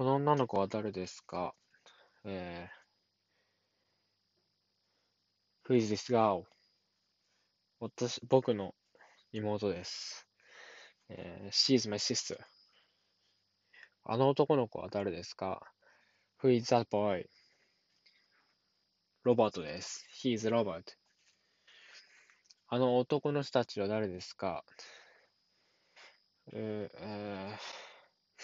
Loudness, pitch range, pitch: -34 LUFS, 100-125 Hz, 105 Hz